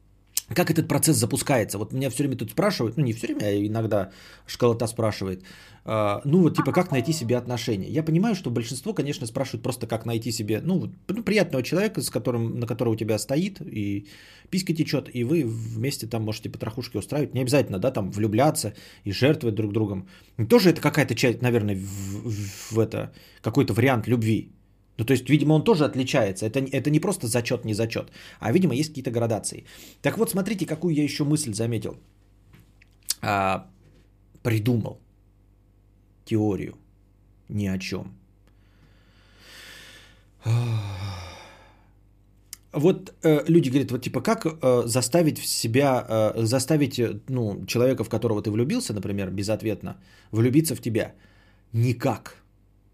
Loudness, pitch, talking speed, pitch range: -25 LUFS, 115 Hz, 155 wpm, 100-135 Hz